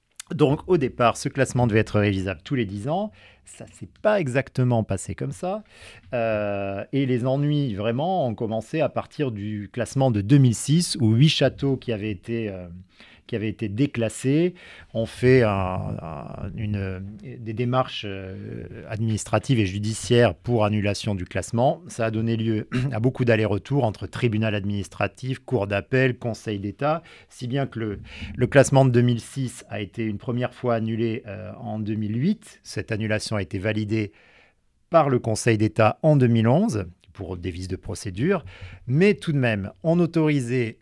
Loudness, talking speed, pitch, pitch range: -24 LUFS, 165 wpm, 115 Hz, 105-130 Hz